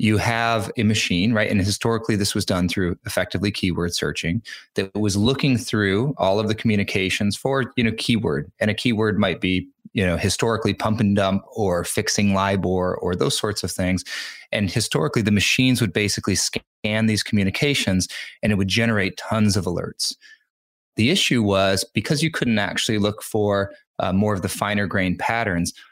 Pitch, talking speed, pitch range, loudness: 105 Hz, 180 wpm, 95-115 Hz, -21 LUFS